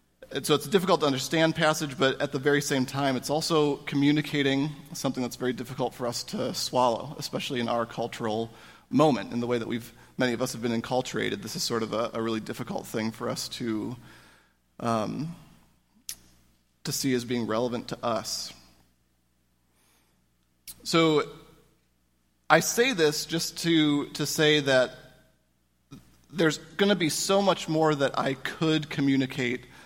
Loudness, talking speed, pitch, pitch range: -27 LUFS, 160 wpm, 130 Hz, 115-150 Hz